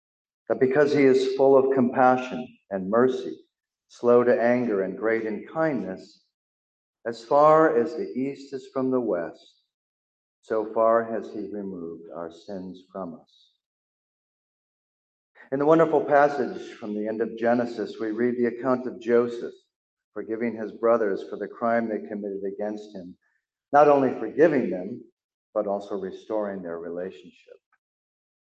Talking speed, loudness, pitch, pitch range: 145 wpm, -24 LUFS, 115 Hz, 100-130 Hz